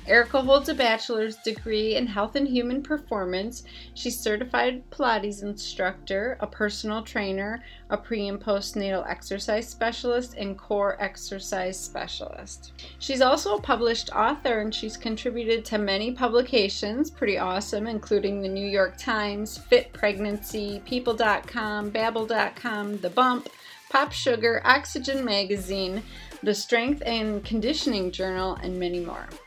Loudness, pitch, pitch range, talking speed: -26 LUFS, 215 Hz, 200-245 Hz, 130 wpm